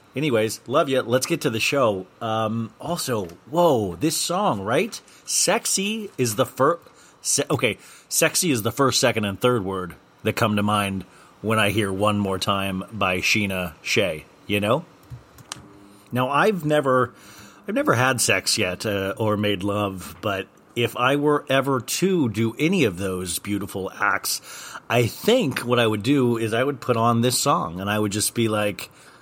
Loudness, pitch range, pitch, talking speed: -22 LUFS, 100-130 Hz, 110 Hz, 175 wpm